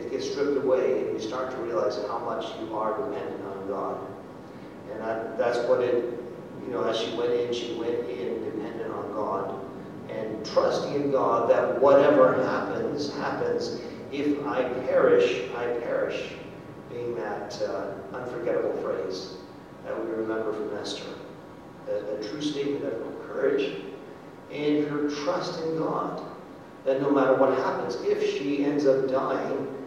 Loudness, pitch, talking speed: -27 LUFS, 165 Hz, 150 wpm